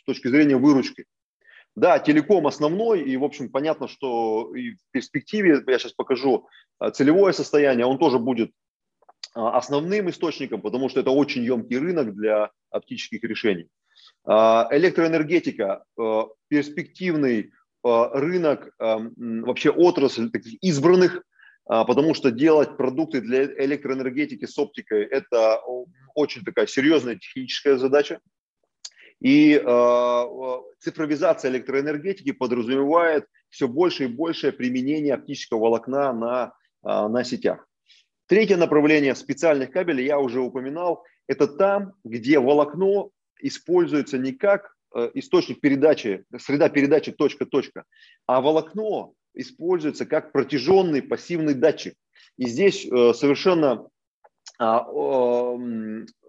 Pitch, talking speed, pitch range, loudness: 145 Hz, 110 wpm, 125-180 Hz, -22 LUFS